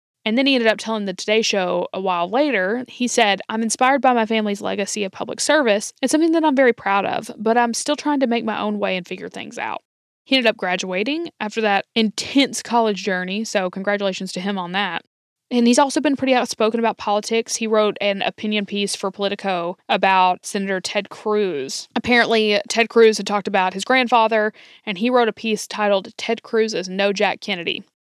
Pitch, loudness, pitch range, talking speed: 215 Hz, -19 LUFS, 200-235 Hz, 210 wpm